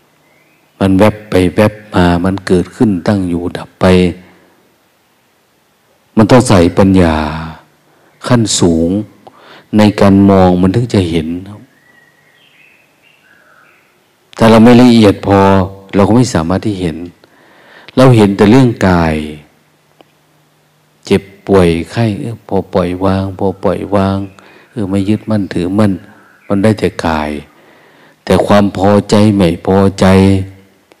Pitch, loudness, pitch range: 95 Hz, -10 LUFS, 90-105 Hz